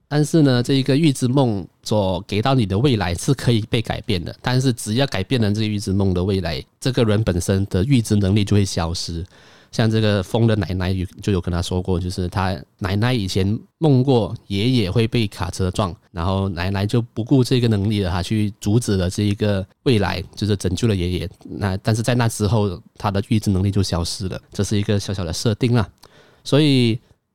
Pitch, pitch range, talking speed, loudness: 105 Hz, 95-120 Hz, 310 characters per minute, -20 LUFS